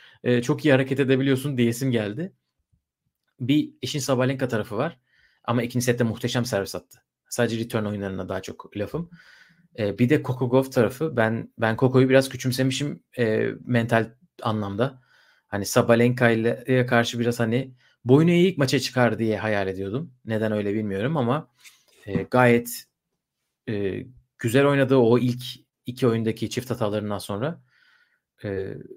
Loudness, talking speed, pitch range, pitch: -23 LUFS, 140 wpm, 110-135 Hz, 125 Hz